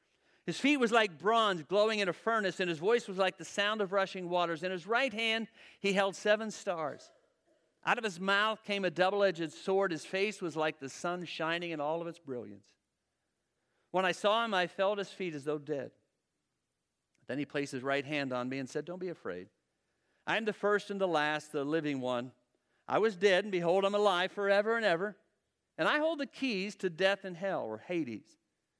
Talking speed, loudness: 215 wpm, -33 LUFS